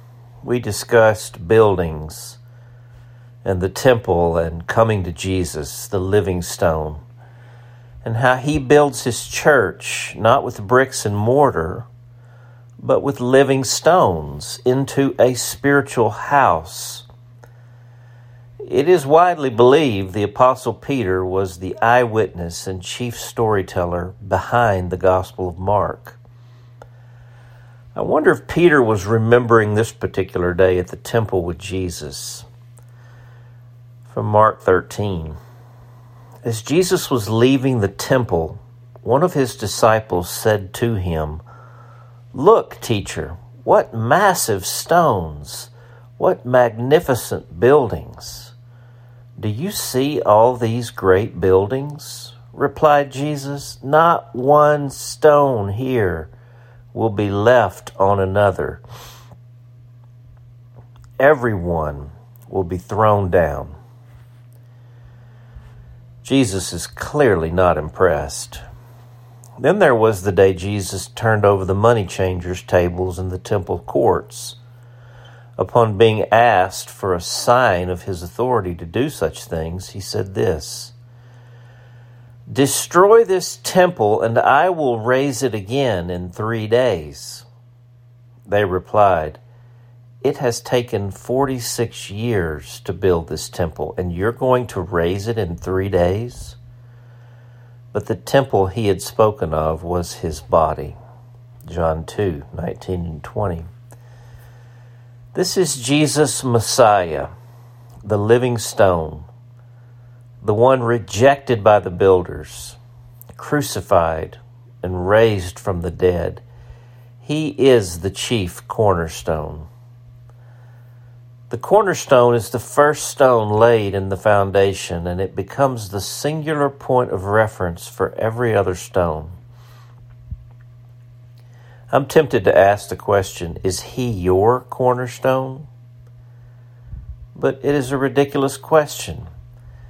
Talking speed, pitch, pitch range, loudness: 110 wpm, 120 Hz, 100-120 Hz, -18 LUFS